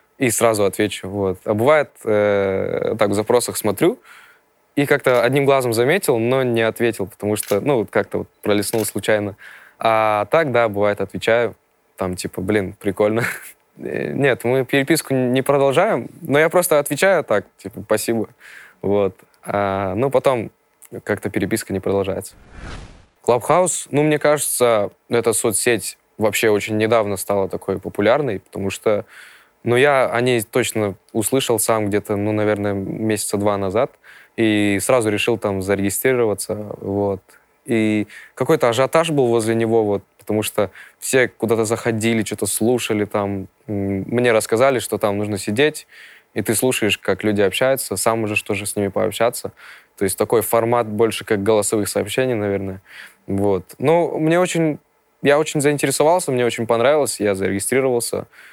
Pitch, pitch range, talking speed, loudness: 110 Hz, 100-125 Hz, 150 wpm, -19 LUFS